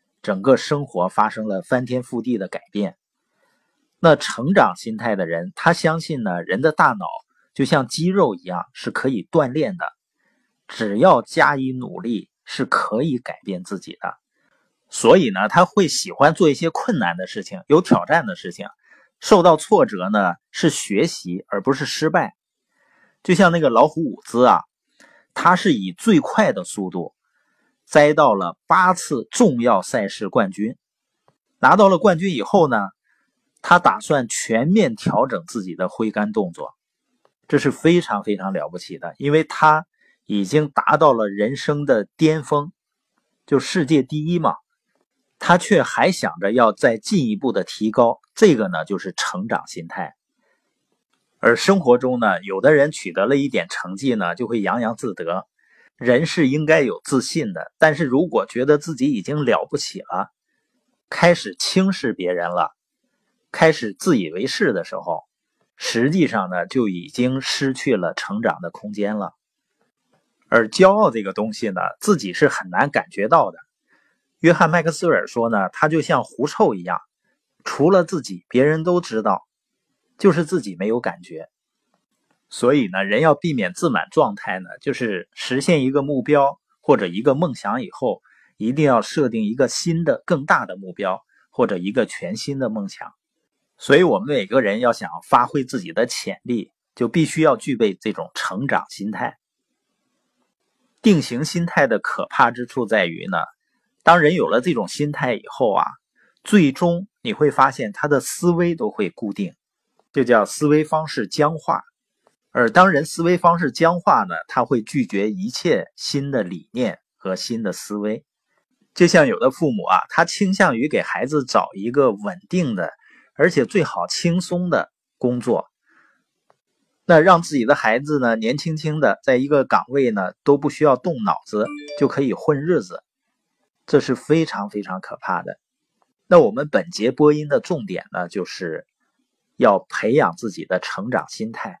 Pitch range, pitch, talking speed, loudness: 125-175 Hz, 150 Hz, 235 characters per minute, -19 LUFS